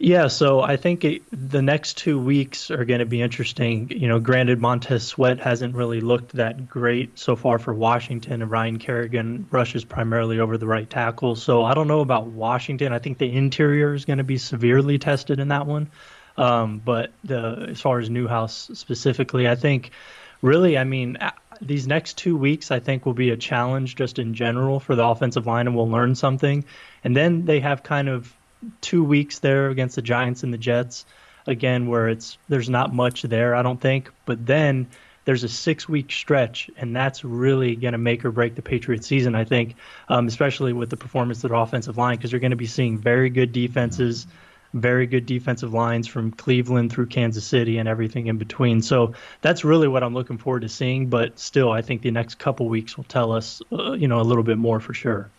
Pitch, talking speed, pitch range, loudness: 125 Hz, 210 wpm, 120-135 Hz, -22 LUFS